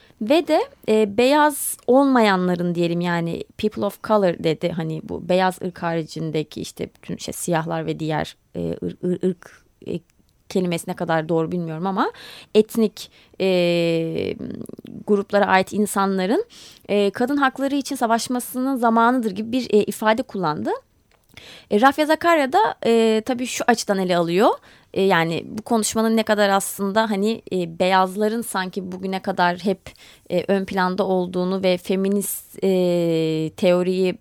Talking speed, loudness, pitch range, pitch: 140 wpm, -21 LUFS, 175-225 Hz, 195 Hz